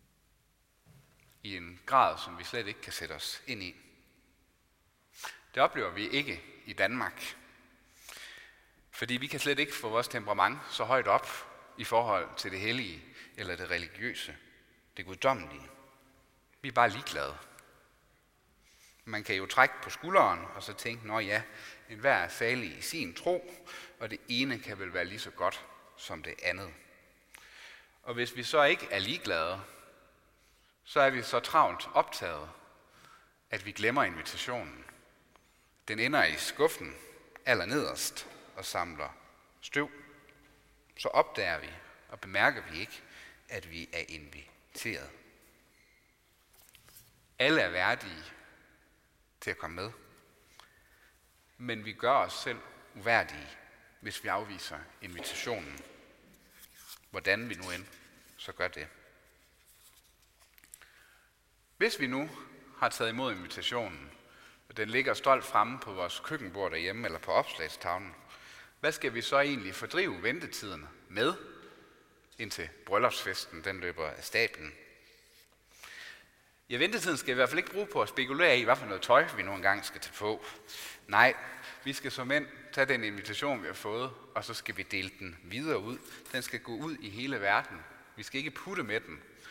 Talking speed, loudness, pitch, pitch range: 150 wpm, -32 LUFS, 130 Hz, 105-145 Hz